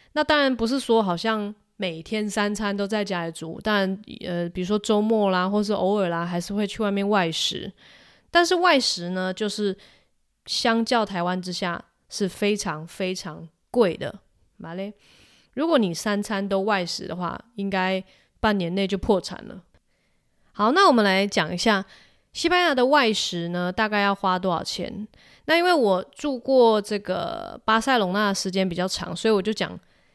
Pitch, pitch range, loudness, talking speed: 200 Hz, 185-220 Hz, -23 LUFS, 245 characters per minute